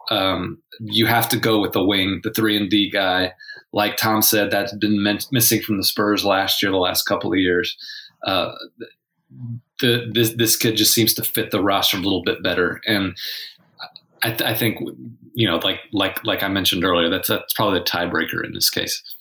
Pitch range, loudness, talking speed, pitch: 100-115 Hz, -18 LUFS, 205 wpm, 110 Hz